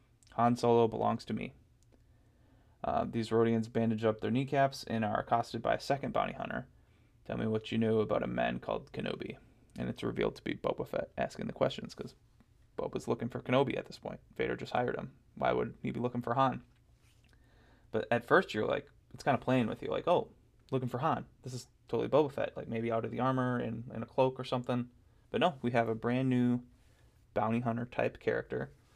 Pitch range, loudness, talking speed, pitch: 110-125 Hz, -34 LUFS, 215 wpm, 120 Hz